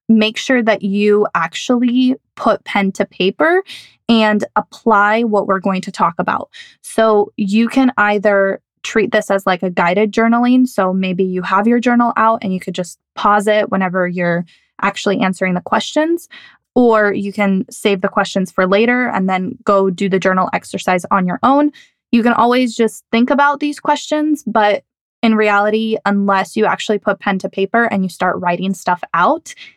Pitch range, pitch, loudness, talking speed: 195-235 Hz, 210 Hz, -15 LUFS, 180 wpm